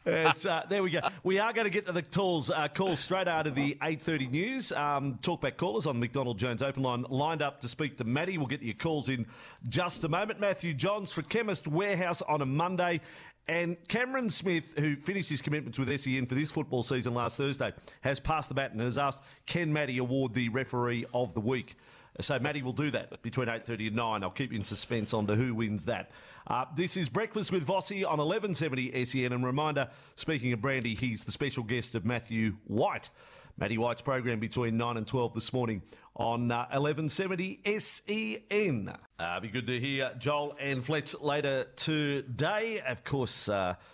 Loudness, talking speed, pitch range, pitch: -32 LUFS, 210 wpm, 125-170 Hz, 140 Hz